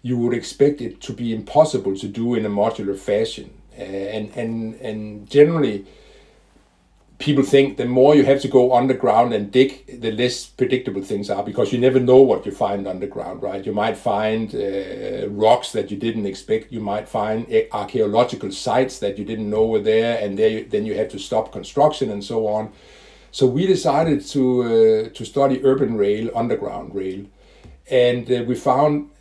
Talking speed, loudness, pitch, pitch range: 180 wpm, -20 LUFS, 115 Hz, 105-130 Hz